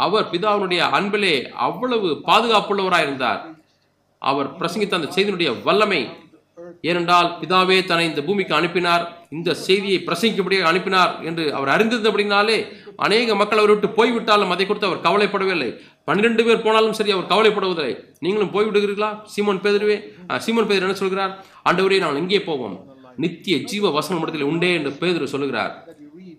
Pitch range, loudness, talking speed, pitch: 170-210 Hz, -19 LUFS, 125 wpm, 195 Hz